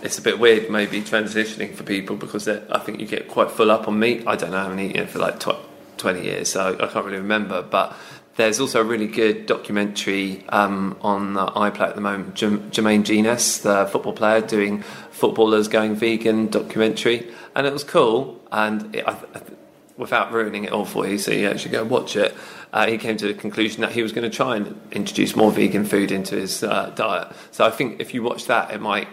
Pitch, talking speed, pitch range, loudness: 105 Hz, 225 wpm, 100-110 Hz, -21 LUFS